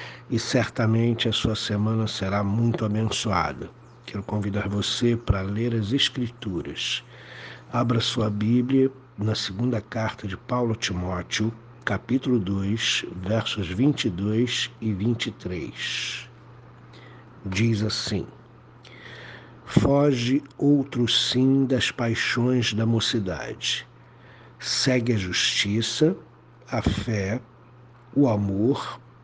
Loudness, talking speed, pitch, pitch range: -25 LUFS, 95 wpm, 115 Hz, 105-120 Hz